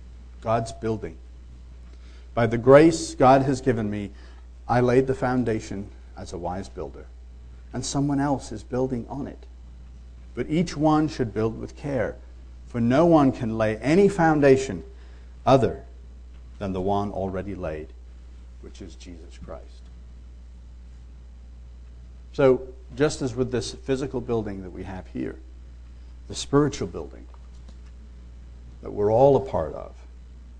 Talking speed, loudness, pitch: 135 wpm, -23 LUFS, 70 Hz